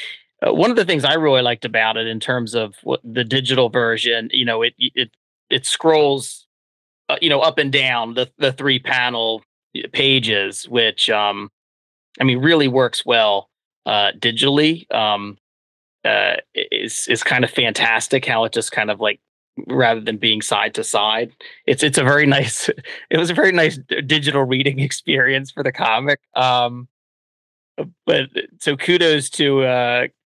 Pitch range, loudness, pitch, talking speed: 115-140 Hz, -17 LUFS, 125 Hz, 165 wpm